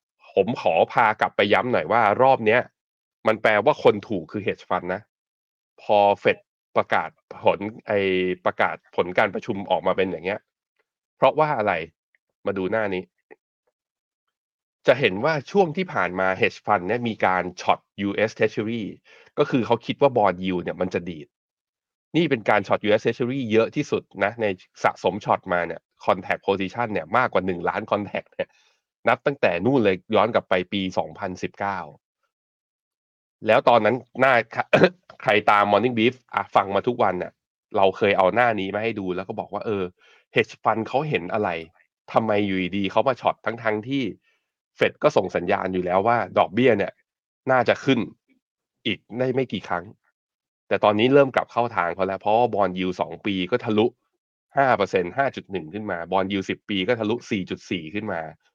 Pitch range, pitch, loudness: 95-120 Hz, 105 Hz, -23 LUFS